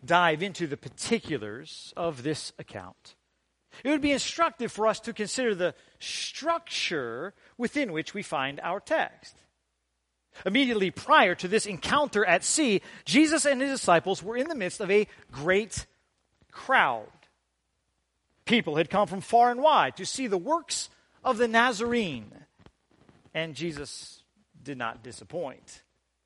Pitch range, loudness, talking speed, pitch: 140-235 Hz, -27 LUFS, 140 wpm, 190 Hz